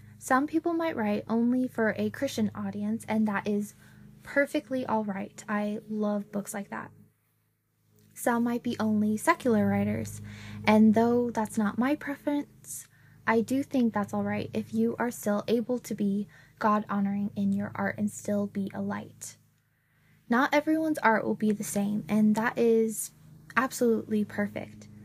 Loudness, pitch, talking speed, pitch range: -28 LUFS, 210 Hz, 155 wpm, 195-230 Hz